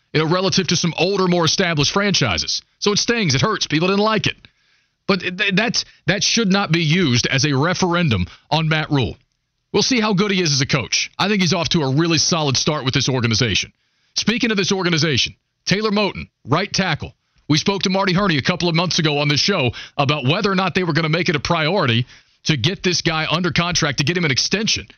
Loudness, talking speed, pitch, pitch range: -18 LUFS, 235 wpm, 170 Hz, 145-190 Hz